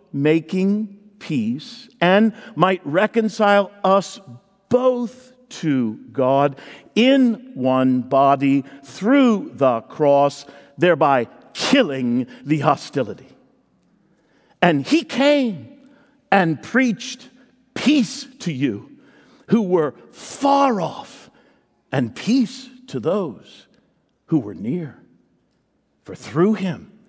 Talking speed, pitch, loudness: 90 wpm, 200 Hz, -19 LUFS